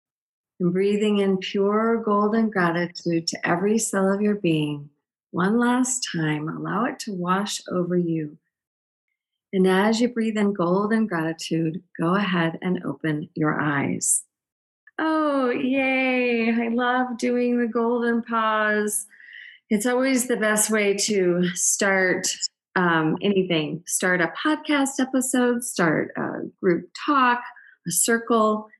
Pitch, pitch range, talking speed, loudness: 210 Hz, 180-245 Hz, 125 wpm, -22 LUFS